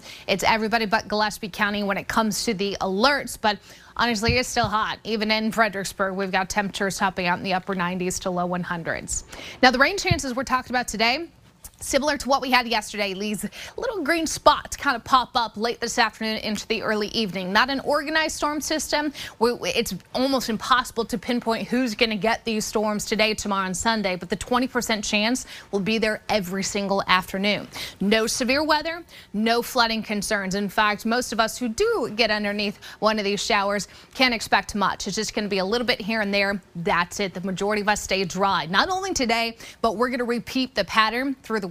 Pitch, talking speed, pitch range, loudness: 220 Hz, 205 wpm, 200-245 Hz, -23 LUFS